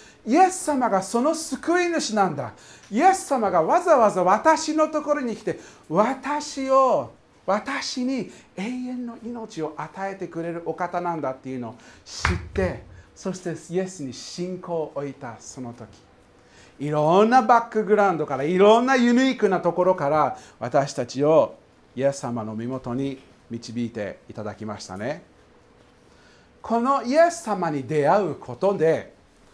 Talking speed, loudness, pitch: 280 characters per minute, -23 LUFS, 190 Hz